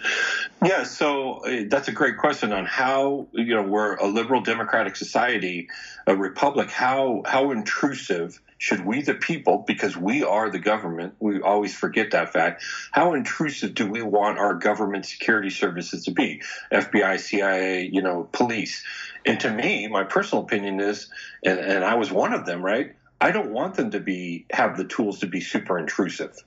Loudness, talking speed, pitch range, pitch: -23 LUFS, 180 wpm, 95-120 Hz, 105 Hz